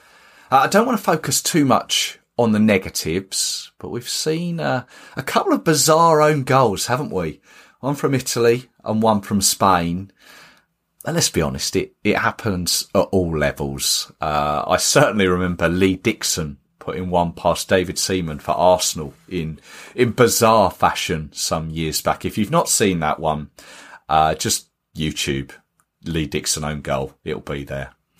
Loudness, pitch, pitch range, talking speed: -19 LUFS, 90 Hz, 75-110 Hz, 160 wpm